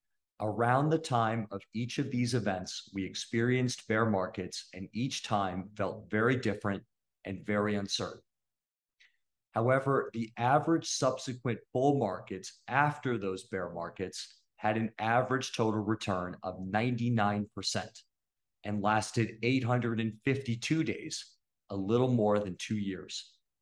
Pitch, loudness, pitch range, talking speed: 110 Hz, -32 LUFS, 100-125 Hz, 120 wpm